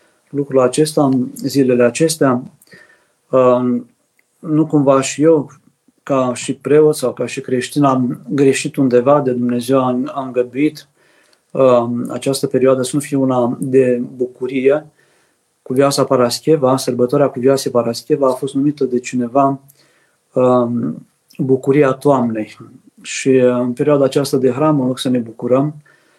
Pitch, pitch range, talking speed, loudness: 135 Hz, 125-145 Hz, 130 wpm, -15 LUFS